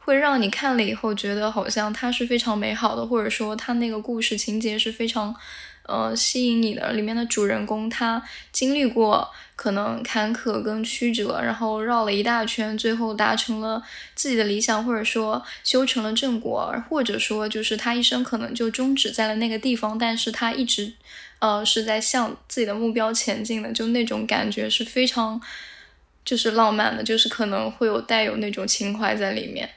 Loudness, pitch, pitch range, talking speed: -23 LUFS, 225 Hz, 215-235 Hz, 285 characters per minute